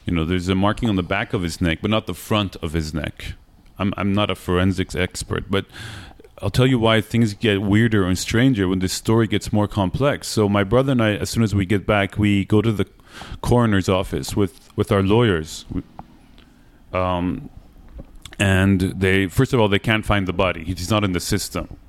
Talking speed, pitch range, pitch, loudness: 210 wpm, 95-110 Hz, 100 Hz, -20 LUFS